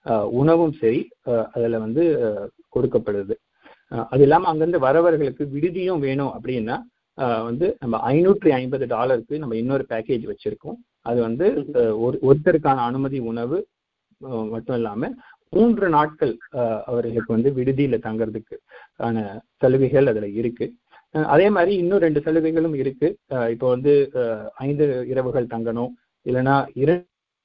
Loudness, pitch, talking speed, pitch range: -21 LUFS, 135 Hz, 115 wpm, 115-165 Hz